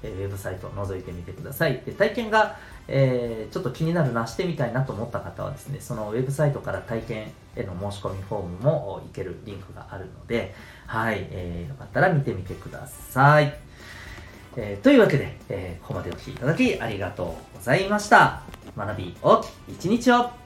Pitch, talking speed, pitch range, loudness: 120 Hz, 405 characters per minute, 100-145 Hz, -24 LUFS